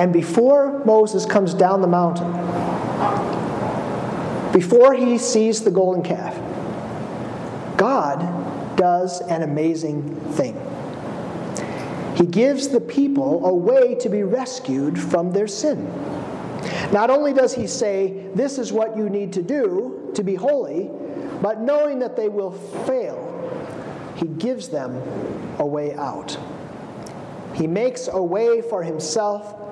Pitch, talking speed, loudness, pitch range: 210 Hz, 125 wpm, -21 LUFS, 175-255 Hz